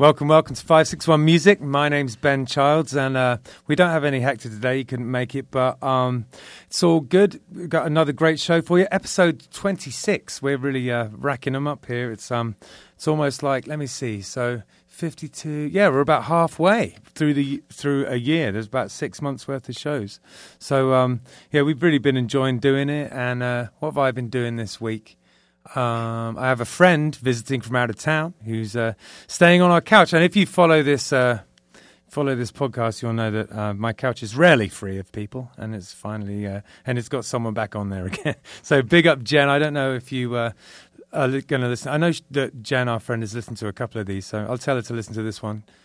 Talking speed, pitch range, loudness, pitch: 235 wpm, 115-150 Hz, -21 LUFS, 135 Hz